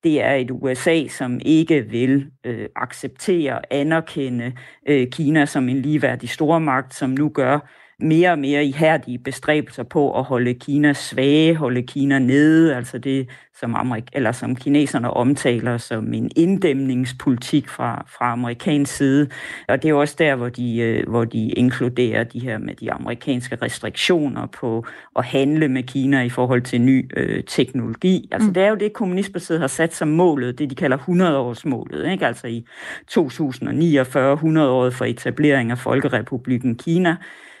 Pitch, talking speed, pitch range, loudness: 135 Hz, 160 wpm, 125-150 Hz, -19 LUFS